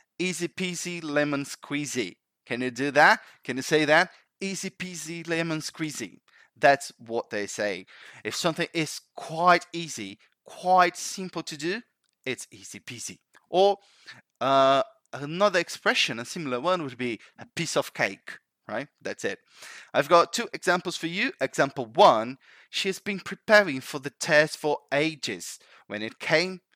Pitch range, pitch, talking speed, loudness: 145-185 Hz, 165 Hz, 150 wpm, -26 LUFS